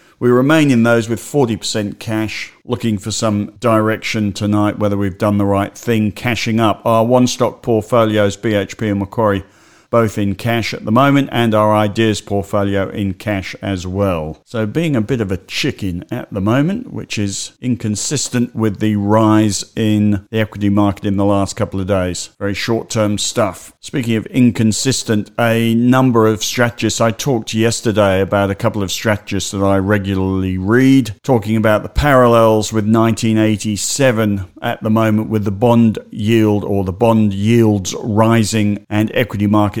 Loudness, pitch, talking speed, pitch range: -15 LUFS, 110 Hz, 165 wpm, 100-115 Hz